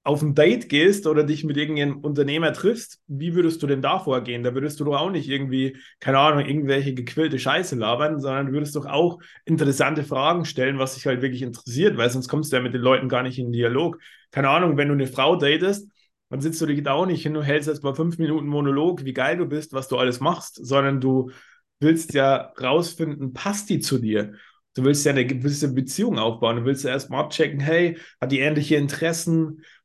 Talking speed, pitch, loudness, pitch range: 220 wpm, 145 Hz, -22 LUFS, 130-160 Hz